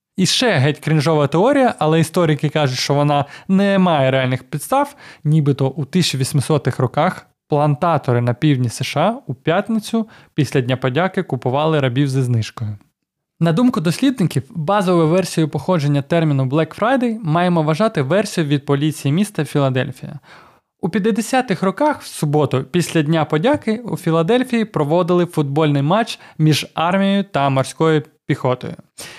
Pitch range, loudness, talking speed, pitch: 145-185 Hz, -17 LUFS, 135 wpm, 155 Hz